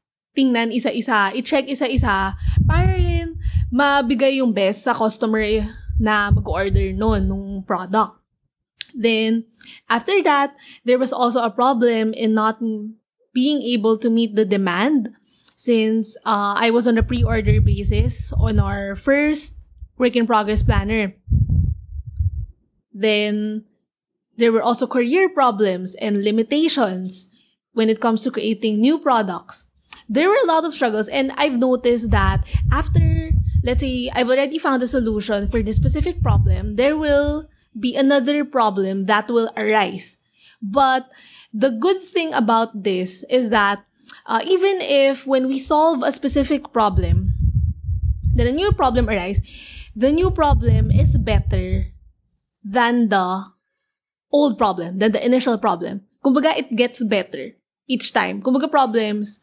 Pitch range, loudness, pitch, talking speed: 195-265 Hz, -19 LUFS, 225 Hz, 135 wpm